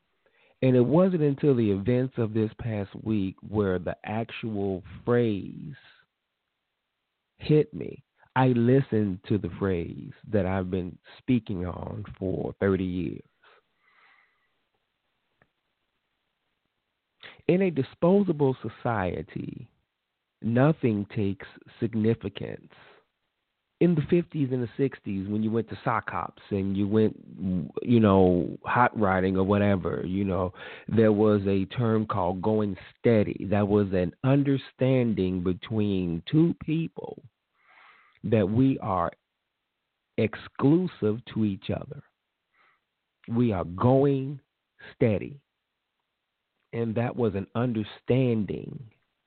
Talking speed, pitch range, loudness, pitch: 110 wpm, 100-125 Hz, -26 LUFS, 110 Hz